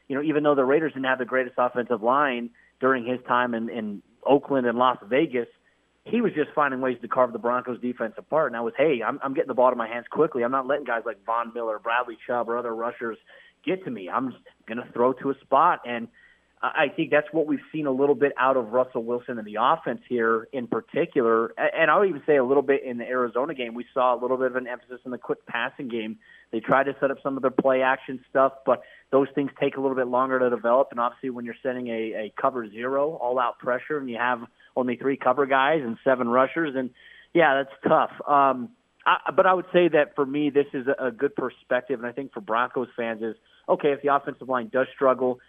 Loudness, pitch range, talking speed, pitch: -25 LUFS, 120-140 Hz, 245 wpm, 130 Hz